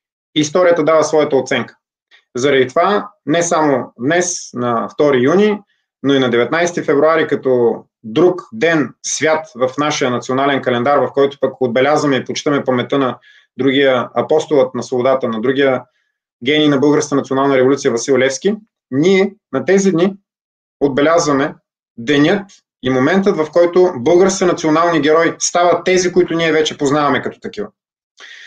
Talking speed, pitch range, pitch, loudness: 140 wpm, 130-175 Hz, 150 Hz, -14 LUFS